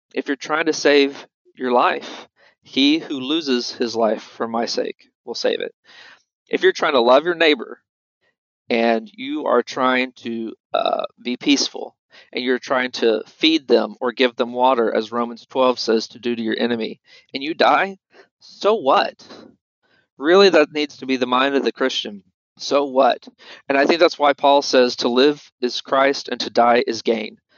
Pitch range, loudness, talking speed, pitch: 125-195 Hz, -19 LUFS, 185 wpm, 140 Hz